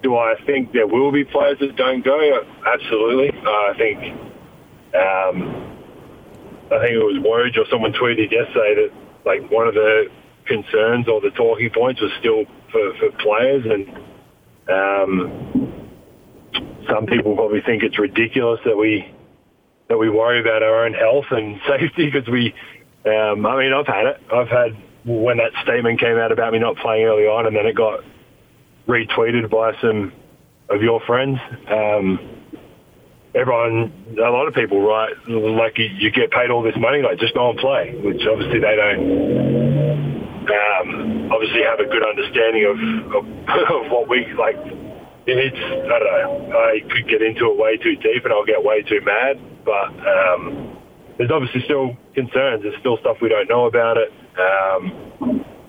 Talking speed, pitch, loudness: 170 wpm, 135 Hz, -18 LUFS